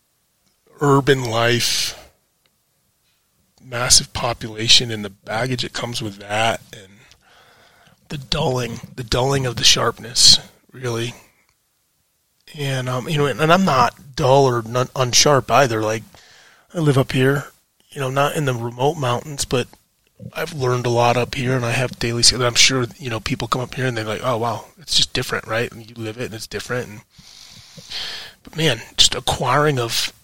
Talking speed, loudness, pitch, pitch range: 170 wpm, -18 LUFS, 125 Hz, 115-140 Hz